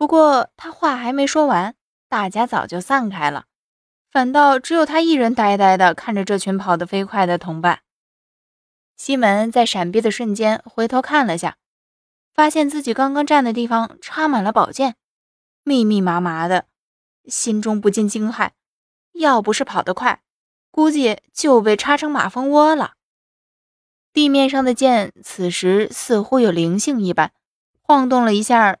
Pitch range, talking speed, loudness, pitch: 200-280 Hz, 230 characters per minute, -17 LUFS, 235 Hz